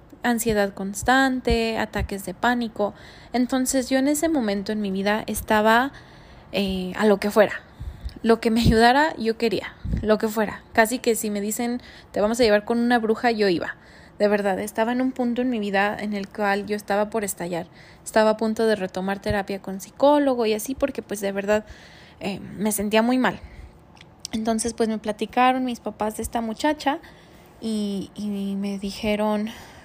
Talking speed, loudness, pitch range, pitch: 180 wpm, -23 LUFS, 205-240 Hz, 215 Hz